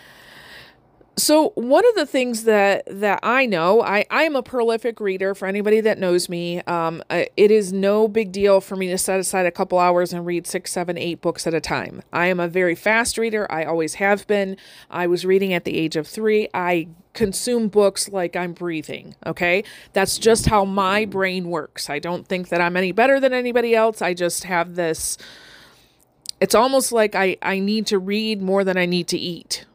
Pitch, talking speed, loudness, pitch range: 190 Hz, 205 wpm, -20 LUFS, 175-215 Hz